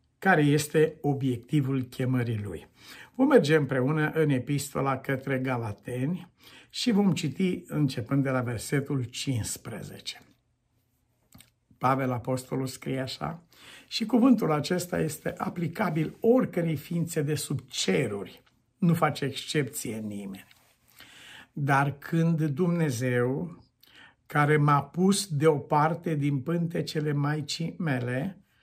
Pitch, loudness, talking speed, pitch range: 145 Hz, -27 LUFS, 105 wpm, 130-165 Hz